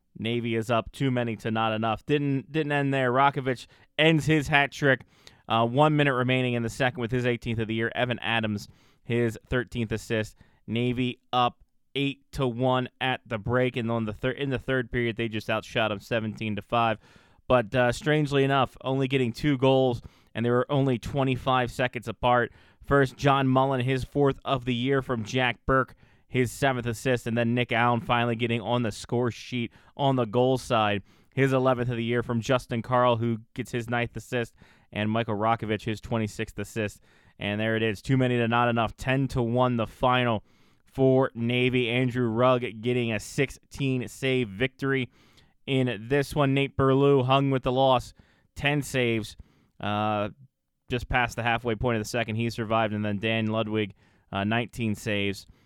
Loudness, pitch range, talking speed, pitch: -26 LUFS, 110-130 Hz, 185 wpm, 120 Hz